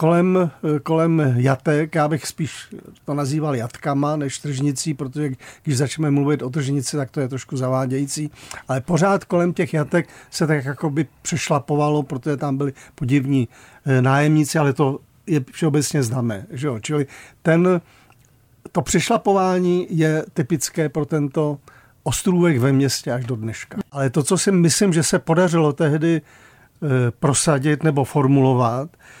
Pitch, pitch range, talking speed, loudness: 150 Hz, 135-160 Hz, 145 wpm, -20 LUFS